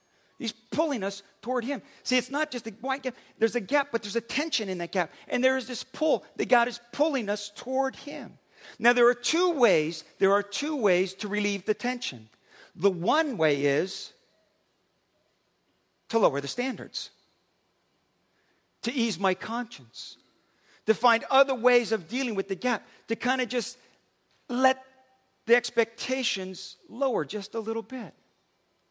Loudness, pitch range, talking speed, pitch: -27 LUFS, 200-260 Hz, 165 wpm, 235 Hz